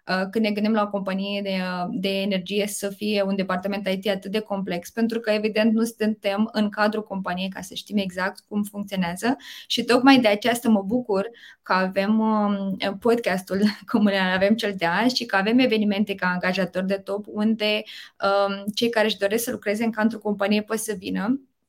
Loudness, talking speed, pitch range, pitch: -23 LUFS, 190 wpm, 195-220 Hz, 205 Hz